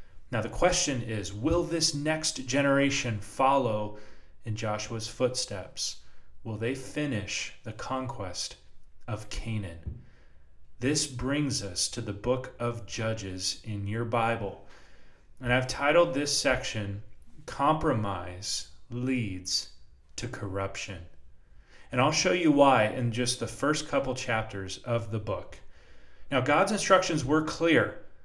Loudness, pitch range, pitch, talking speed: -29 LUFS, 100-140 Hz, 115 Hz, 125 wpm